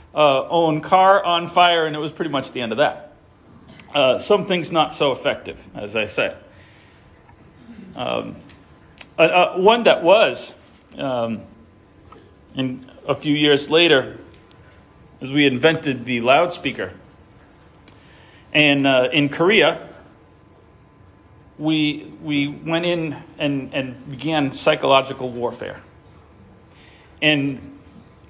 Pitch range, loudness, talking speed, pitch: 130-160 Hz, -18 LUFS, 110 wpm, 145 Hz